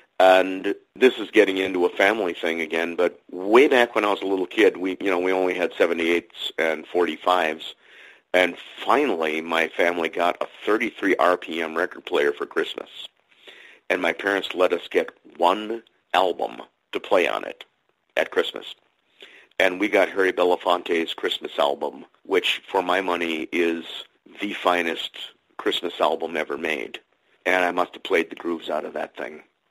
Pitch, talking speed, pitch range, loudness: 90 Hz, 170 wpm, 85-95 Hz, -23 LUFS